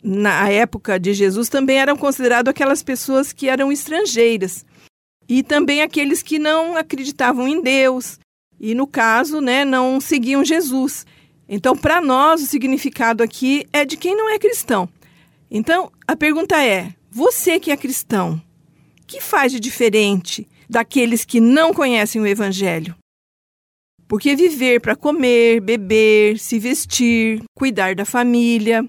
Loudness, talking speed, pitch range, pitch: -16 LUFS, 140 wpm, 215-285 Hz, 255 Hz